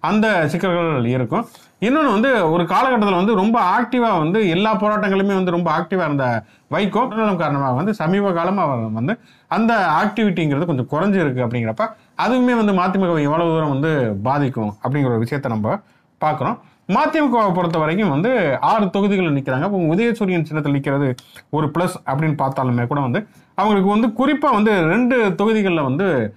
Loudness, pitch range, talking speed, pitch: -18 LUFS, 140-215 Hz, 150 wpm, 175 Hz